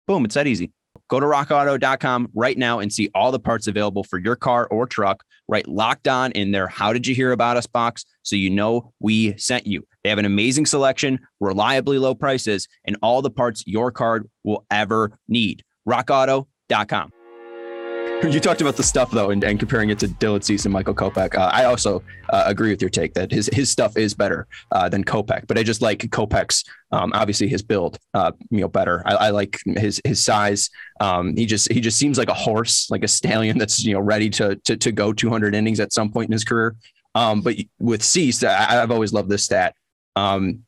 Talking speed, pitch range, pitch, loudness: 215 wpm, 105-125 Hz, 115 Hz, -20 LUFS